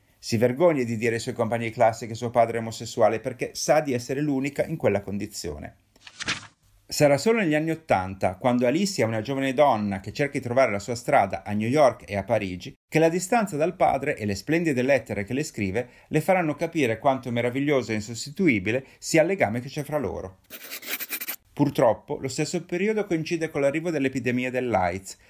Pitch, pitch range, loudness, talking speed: 125 Hz, 110-150 Hz, -25 LUFS, 190 wpm